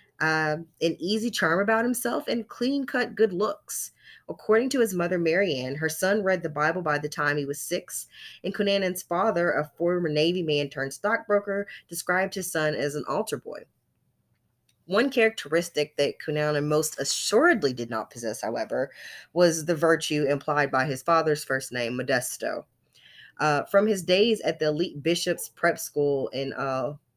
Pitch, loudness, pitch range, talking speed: 165 Hz, -26 LUFS, 145-195 Hz, 165 wpm